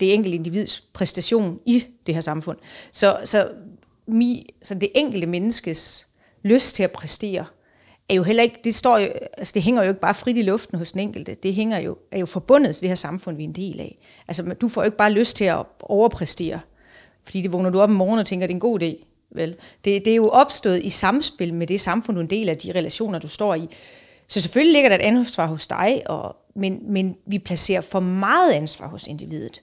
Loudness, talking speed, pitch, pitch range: -20 LUFS, 235 wpm, 195 Hz, 175-220 Hz